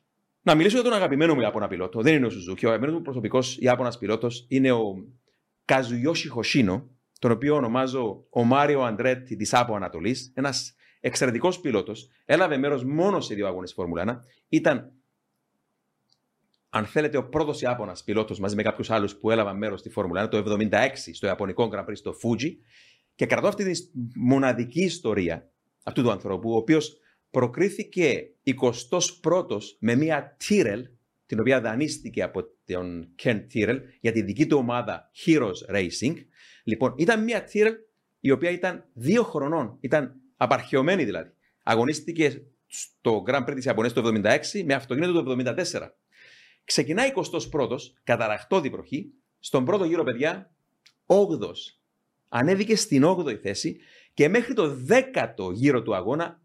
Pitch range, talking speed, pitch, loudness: 115-160 Hz, 150 wpm, 130 Hz, -25 LUFS